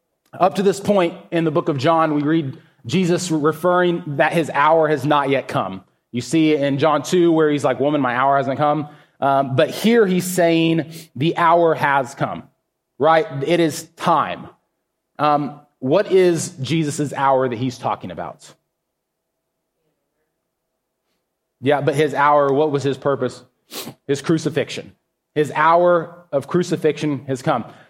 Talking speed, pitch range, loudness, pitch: 155 wpm, 140-165 Hz, -18 LUFS, 155 Hz